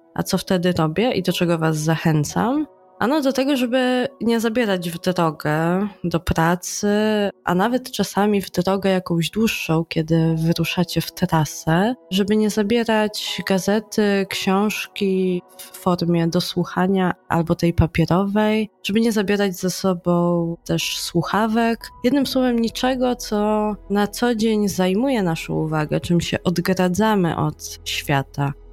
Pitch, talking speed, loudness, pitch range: 190 Hz, 130 wpm, -20 LUFS, 170-215 Hz